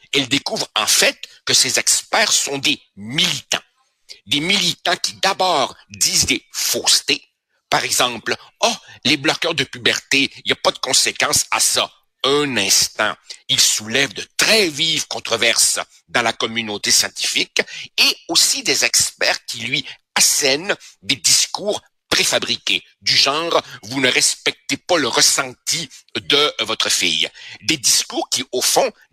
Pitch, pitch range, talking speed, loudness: 140 Hz, 115-150 Hz, 145 wpm, -16 LUFS